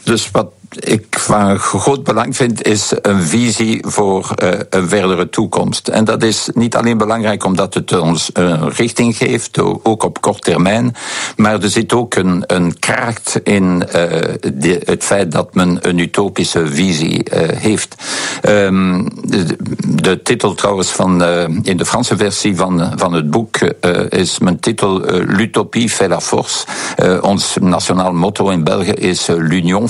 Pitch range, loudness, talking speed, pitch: 90-115 Hz, -13 LUFS, 140 wpm, 100 Hz